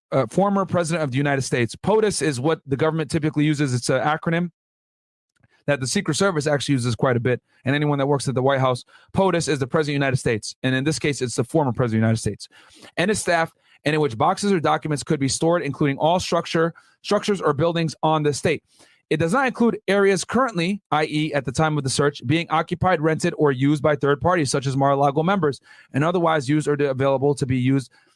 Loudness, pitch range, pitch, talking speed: -21 LUFS, 140-170 Hz, 150 Hz, 235 wpm